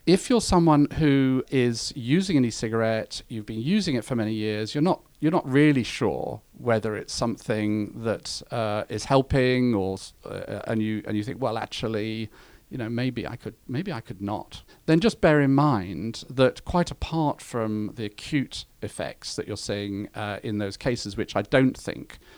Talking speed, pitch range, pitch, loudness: 190 wpm, 110-145 Hz, 120 Hz, -25 LUFS